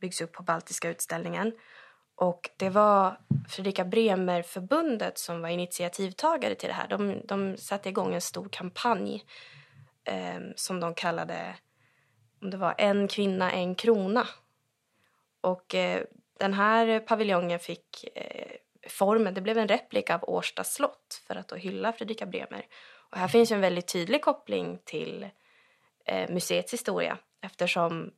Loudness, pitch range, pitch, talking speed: -29 LUFS, 180-225 Hz, 195 Hz, 145 wpm